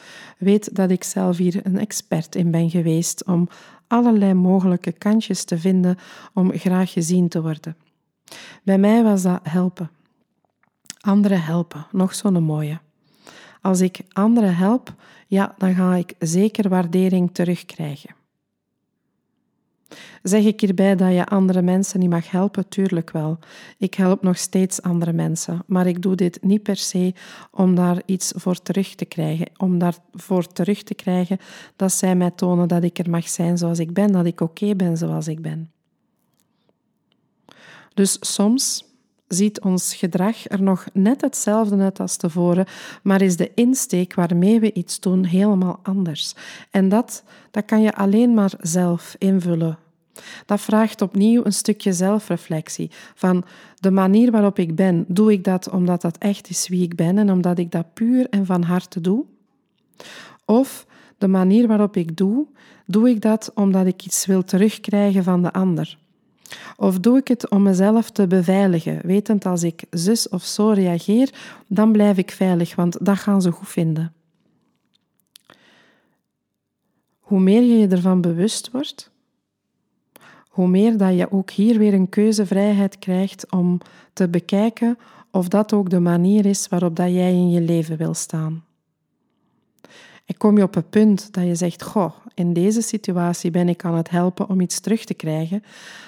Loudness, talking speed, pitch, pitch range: -19 LUFS, 160 wpm, 190 Hz, 175-210 Hz